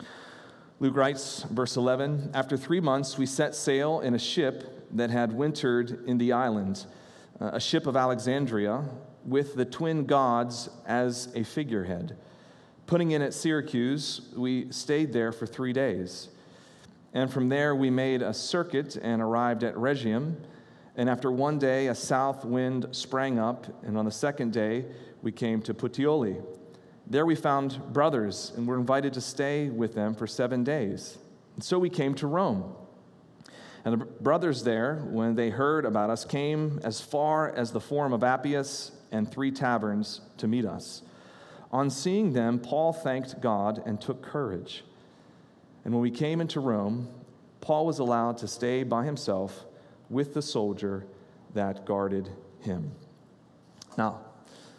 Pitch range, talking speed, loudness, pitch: 115-140 Hz, 155 wpm, -29 LUFS, 125 Hz